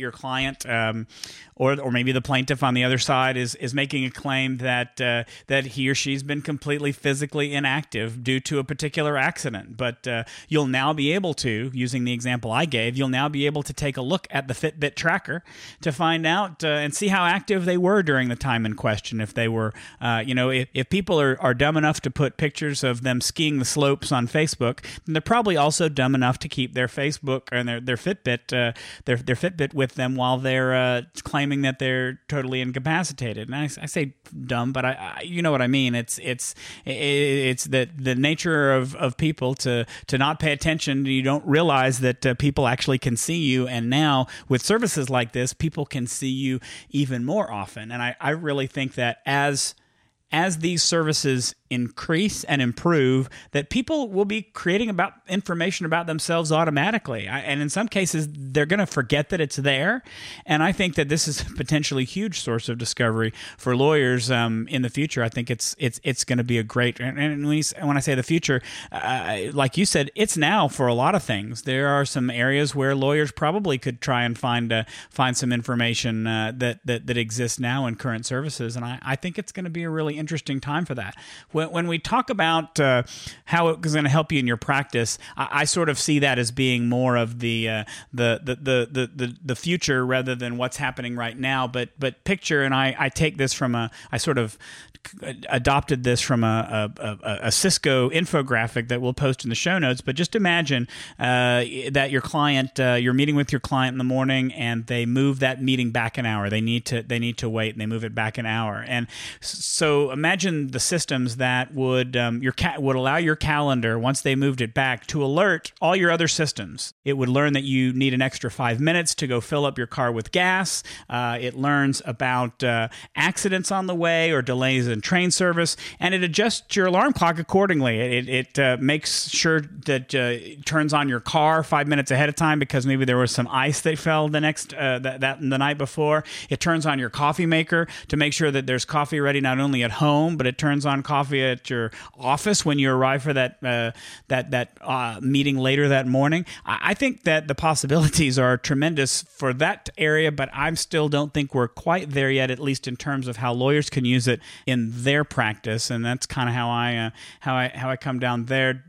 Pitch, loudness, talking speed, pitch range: 135 Hz, -23 LUFS, 220 wpm, 125-150 Hz